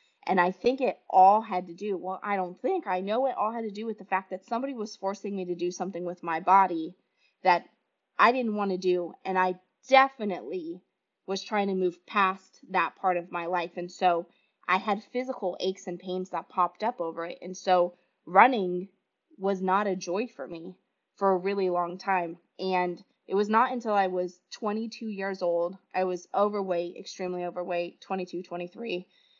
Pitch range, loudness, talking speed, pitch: 180-205 Hz, -28 LUFS, 195 wpm, 185 Hz